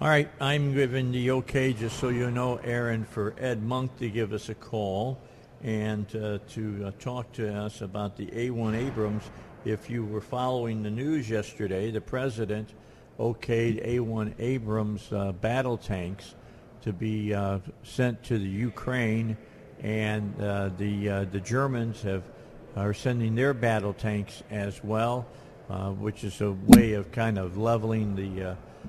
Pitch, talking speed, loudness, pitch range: 110 Hz, 160 wpm, -29 LUFS, 105-125 Hz